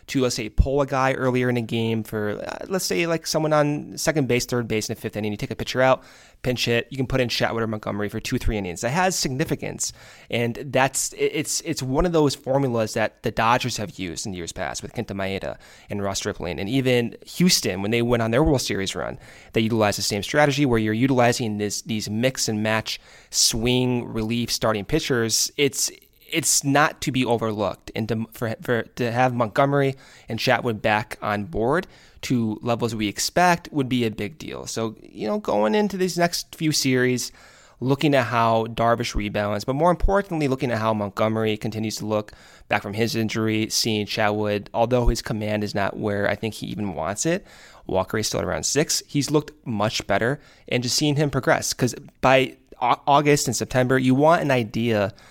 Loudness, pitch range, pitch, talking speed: -23 LUFS, 105-135 Hz, 120 Hz, 205 wpm